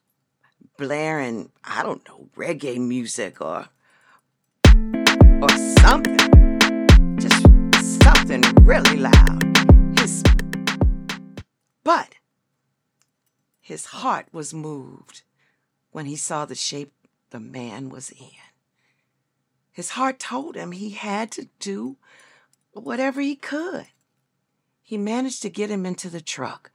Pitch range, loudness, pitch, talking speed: 135-220 Hz, -17 LUFS, 170 Hz, 105 wpm